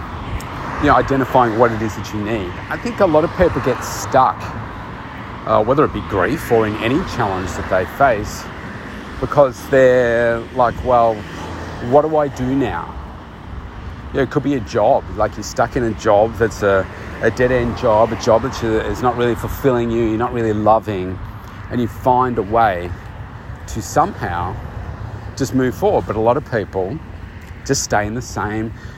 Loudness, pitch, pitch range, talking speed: -17 LUFS, 115 Hz, 105-125 Hz, 180 wpm